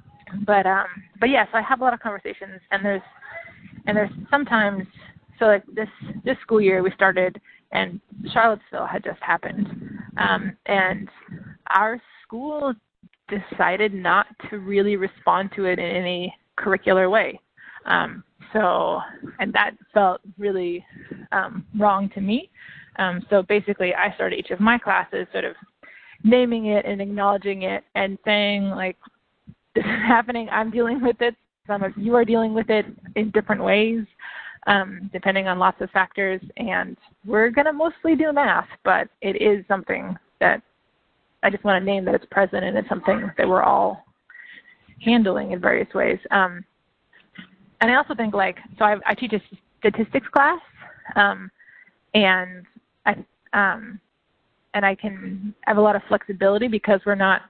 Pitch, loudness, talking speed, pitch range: 205 Hz, -21 LUFS, 160 wpm, 195-225 Hz